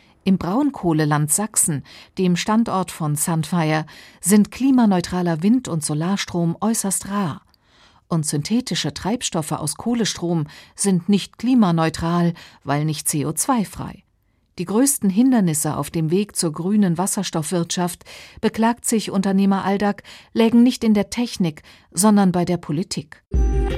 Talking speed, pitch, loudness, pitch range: 120 wpm, 180 Hz, -20 LUFS, 165-210 Hz